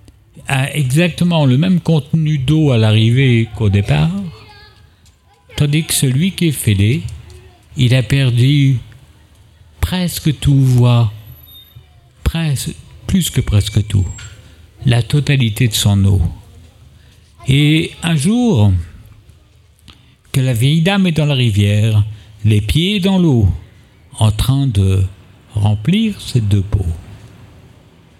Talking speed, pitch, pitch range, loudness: 115 wpm, 115 Hz, 100-145 Hz, -14 LUFS